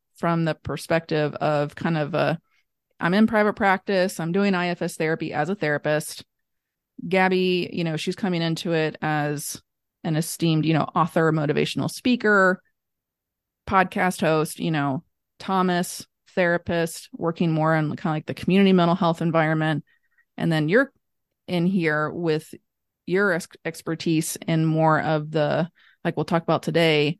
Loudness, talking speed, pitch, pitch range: -23 LUFS, 150 wpm, 165 Hz, 155-185 Hz